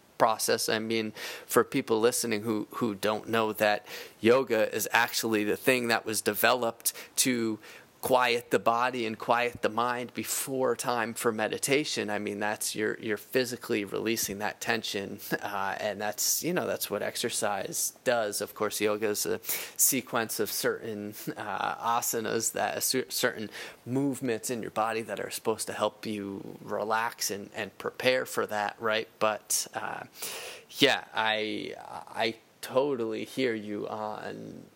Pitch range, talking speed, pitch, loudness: 105-120 Hz, 150 wpm, 110 Hz, -29 LUFS